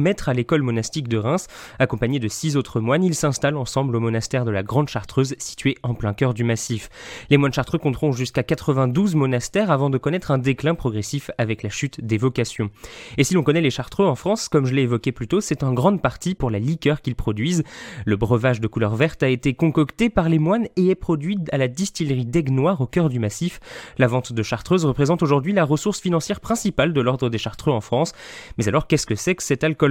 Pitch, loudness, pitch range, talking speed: 140 Hz, -21 LUFS, 120-165 Hz, 225 wpm